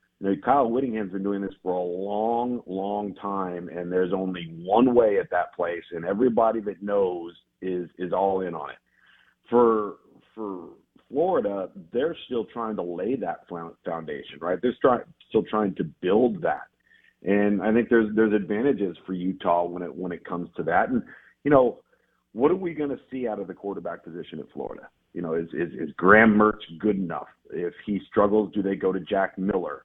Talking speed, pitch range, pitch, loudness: 190 wpm, 90-110 Hz, 100 Hz, -25 LUFS